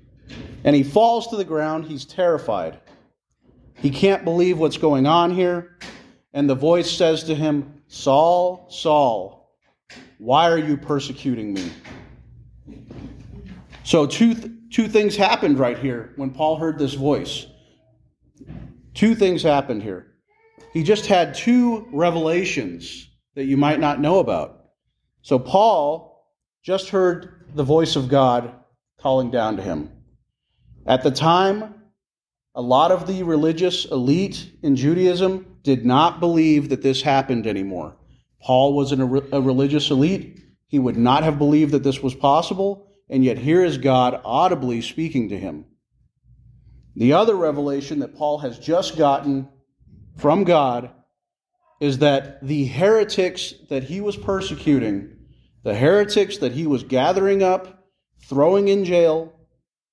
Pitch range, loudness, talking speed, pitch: 135-180 Hz, -19 LUFS, 140 wpm, 150 Hz